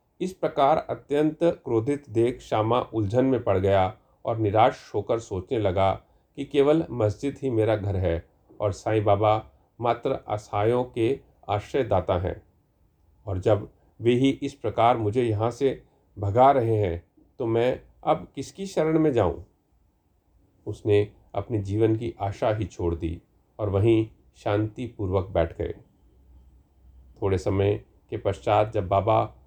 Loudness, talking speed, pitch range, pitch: -25 LUFS, 140 wpm, 95-120 Hz, 105 Hz